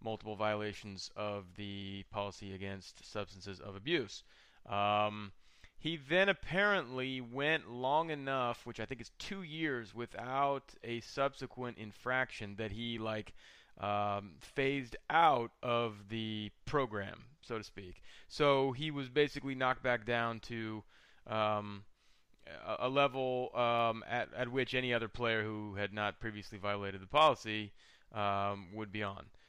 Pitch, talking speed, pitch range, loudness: 110 Hz, 140 wpm, 105-130 Hz, -36 LUFS